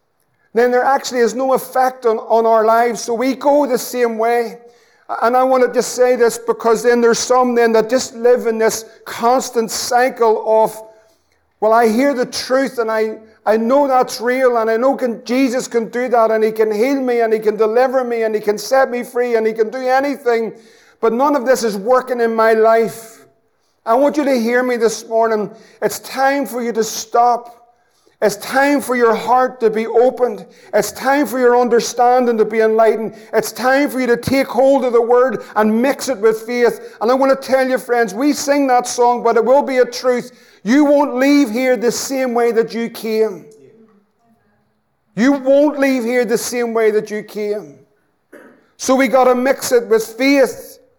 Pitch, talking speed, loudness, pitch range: 240 Hz, 205 wpm, -15 LUFS, 225-255 Hz